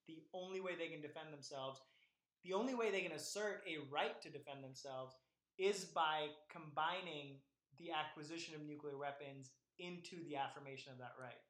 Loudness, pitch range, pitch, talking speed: -46 LUFS, 140-170 Hz, 155 Hz, 165 wpm